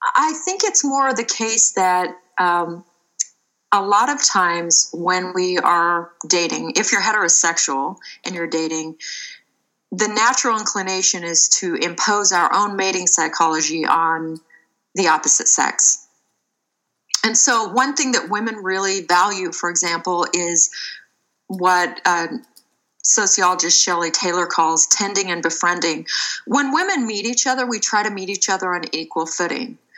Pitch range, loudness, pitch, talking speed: 170-220 Hz, -17 LUFS, 185 Hz, 140 wpm